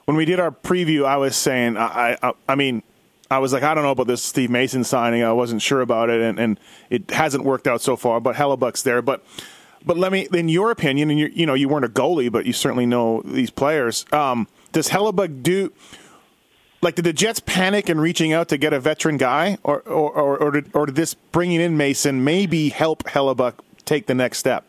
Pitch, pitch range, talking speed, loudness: 145 Hz, 125-160 Hz, 230 wpm, -20 LUFS